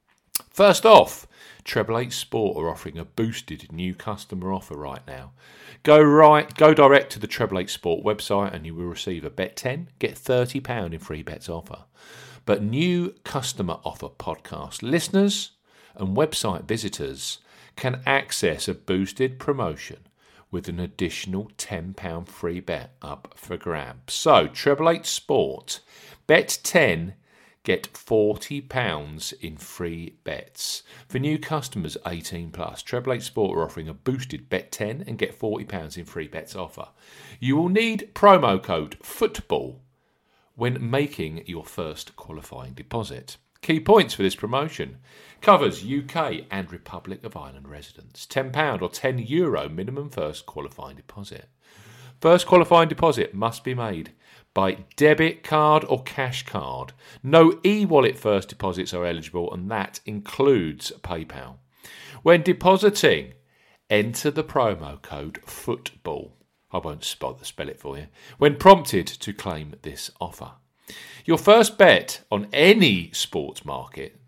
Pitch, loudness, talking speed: 110 Hz, -22 LUFS, 145 wpm